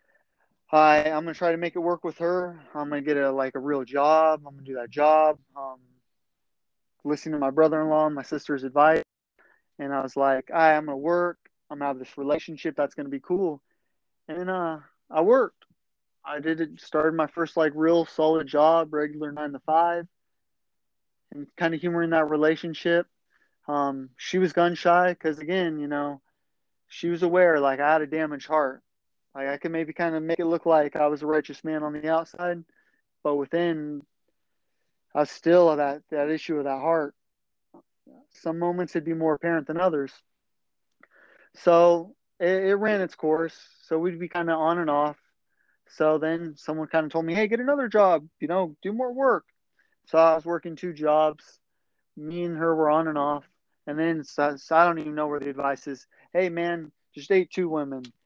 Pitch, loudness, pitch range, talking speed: 155 Hz, -25 LUFS, 145-170 Hz, 195 wpm